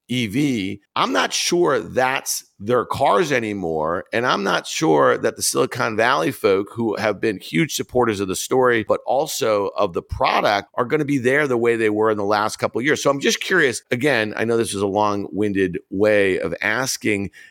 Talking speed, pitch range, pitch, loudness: 200 wpm, 105-130 Hz, 110 Hz, -20 LUFS